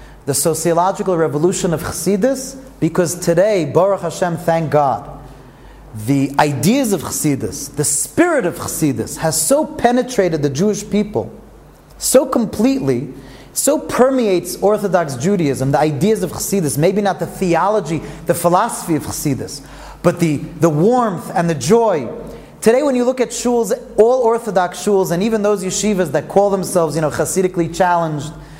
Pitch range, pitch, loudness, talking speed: 150-210 Hz, 175 Hz, -16 LUFS, 145 wpm